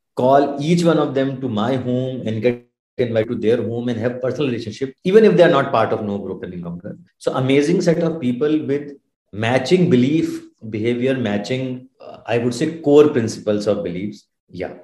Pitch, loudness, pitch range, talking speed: 130 Hz, -18 LUFS, 115-145 Hz, 195 wpm